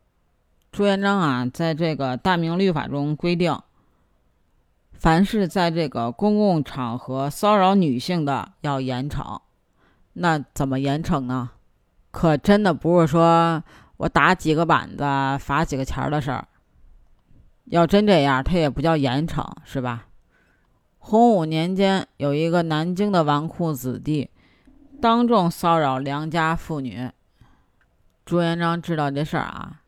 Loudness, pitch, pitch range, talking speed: -21 LUFS, 155 Hz, 130-170 Hz, 200 characters per minute